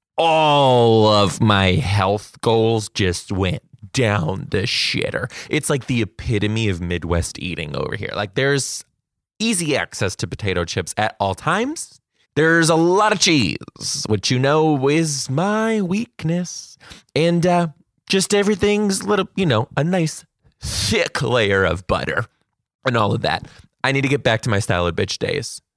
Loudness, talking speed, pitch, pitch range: -19 LUFS, 160 wpm, 135 Hz, 105-165 Hz